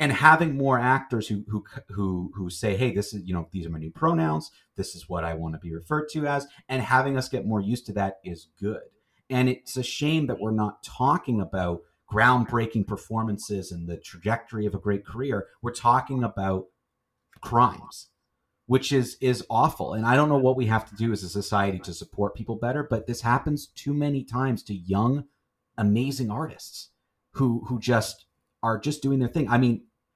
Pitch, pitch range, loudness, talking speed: 115 Hz, 100-130 Hz, -26 LUFS, 200 wpm